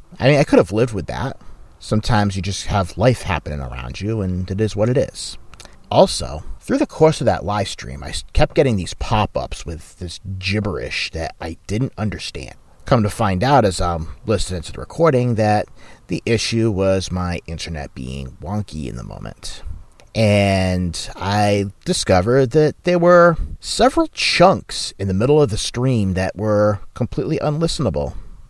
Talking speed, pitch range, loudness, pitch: 175 wpm, 90-120 Hz, -18 LUFS, 100 Hz